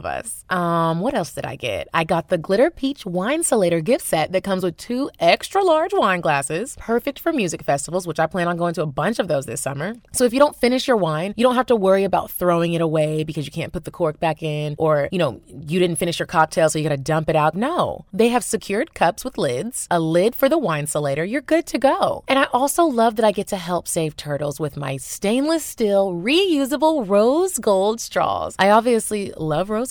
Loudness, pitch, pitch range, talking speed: -20 LUFS, 190 Hz, 160-250 Hz, 235 wpm